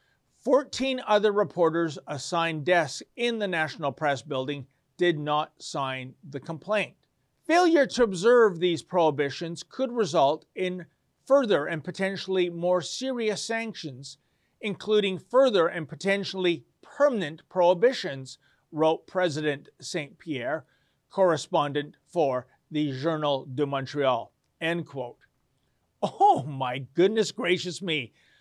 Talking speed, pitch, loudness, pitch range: 110 wpm, 170 Hz, -26 LUFS, 145-205 Hz